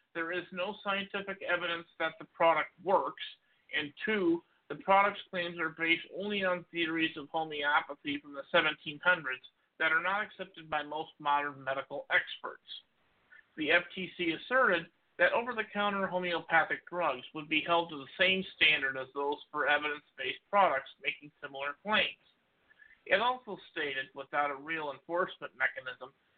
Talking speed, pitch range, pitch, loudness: 150 wpm, 145-190 Hz, 165 Hz, -32 LUFS